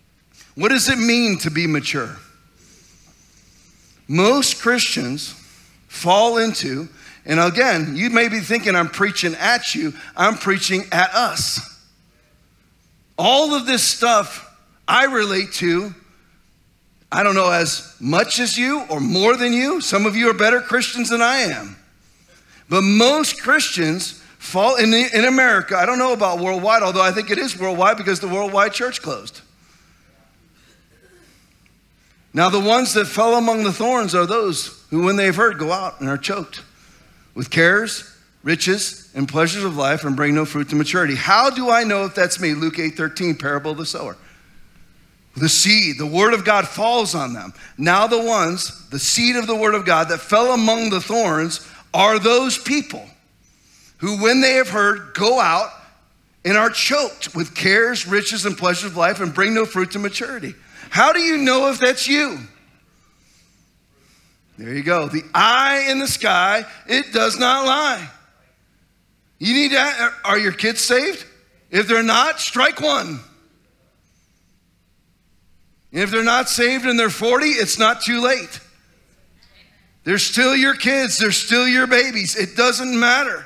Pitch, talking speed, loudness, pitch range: 210 Hz, 160 wpm, -17 LUFS, 170-245 Hz